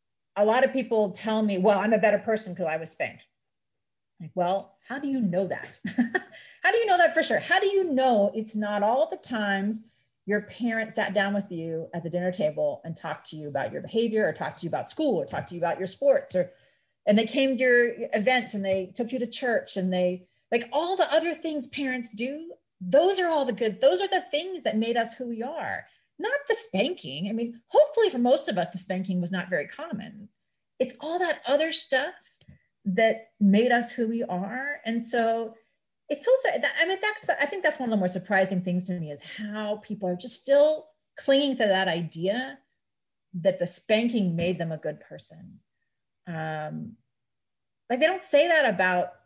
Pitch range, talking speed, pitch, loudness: 185-275 Hz, 215 wpm, 220 Hz, -26 LUFS